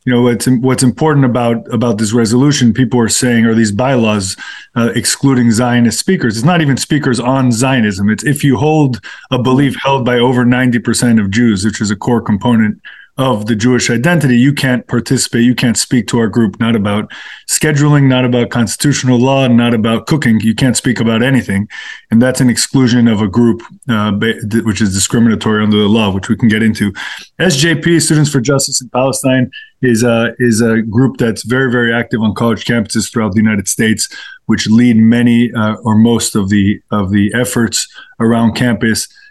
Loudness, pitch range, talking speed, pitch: -12 LUFS, 110-130 Hz, 190 wpm, 120 Hz